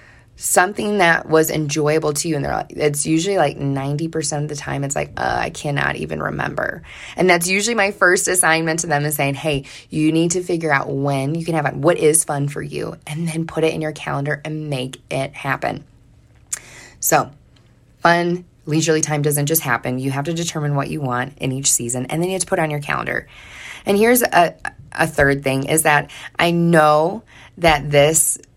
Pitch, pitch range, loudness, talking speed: 150 Hz, 140-165 Hz, -18 LUFS, 210 wpm